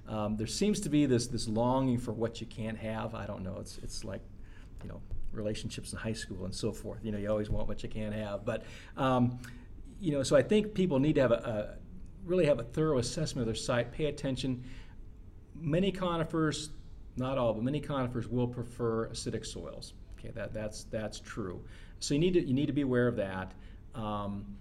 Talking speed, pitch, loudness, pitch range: 215 wpm, 115 Hz, -33 LUFS, 100-130 Hz